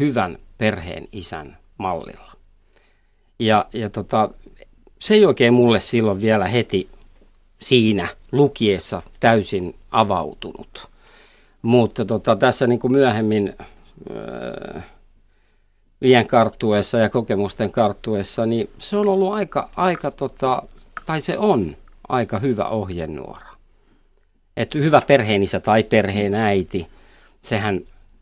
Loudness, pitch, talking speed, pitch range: -19 LUFS, 115 Hz, 100 wpm, 105-130 Hz